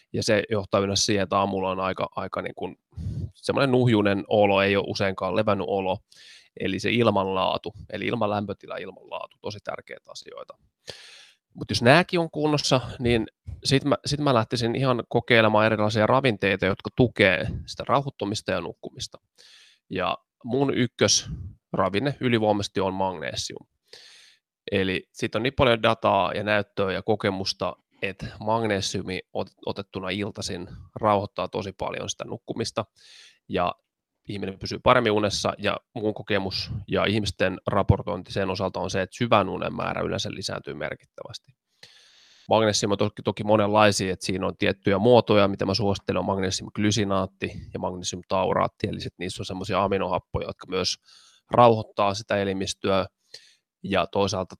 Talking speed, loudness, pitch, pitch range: 140 wpm, -25 LUFS, 105 Hz, 95-115 Hz